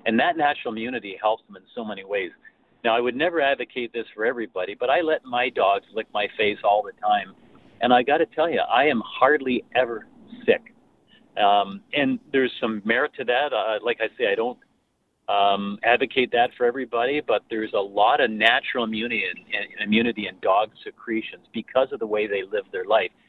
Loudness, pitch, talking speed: -23 LUFS, 120 Hz, 200 wpm